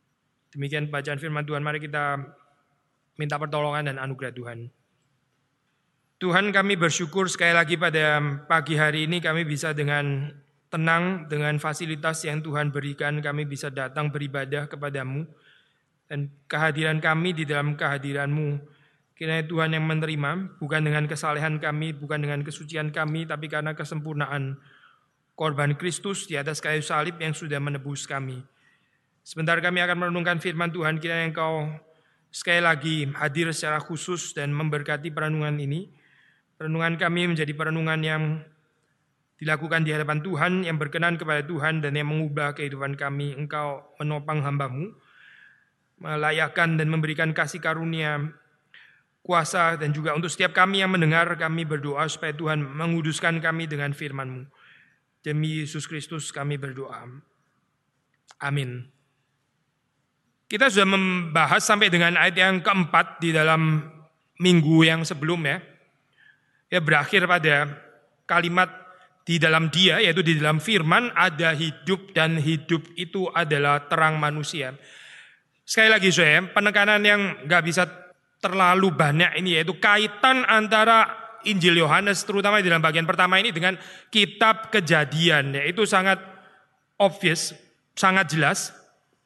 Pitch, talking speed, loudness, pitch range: 155 Hz, 130 wpm, -23 LUFS, 150-175 Hz